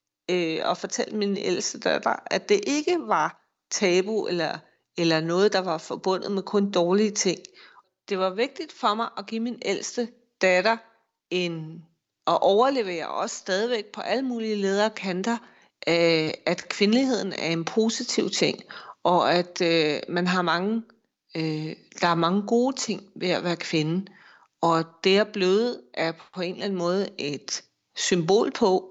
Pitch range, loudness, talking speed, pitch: 175-225 Hz, -25 LUFS, 150 wpm, 190 Hz